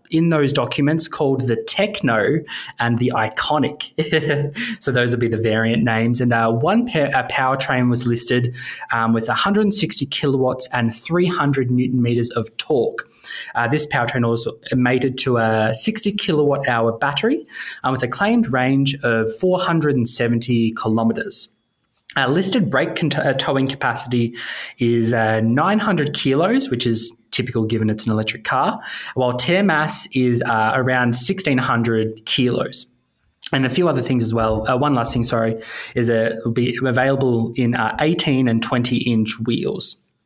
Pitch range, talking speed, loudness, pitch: 115-145 Hz, 150 wpm, -18 LUFS, 125 Hz